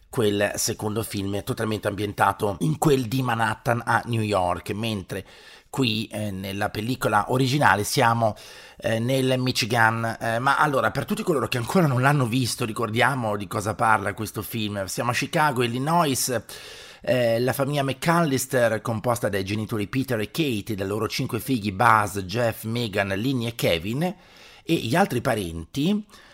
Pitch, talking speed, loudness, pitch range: 115 Hz, 155 wpm, -24 LUFS, 105-130 Hz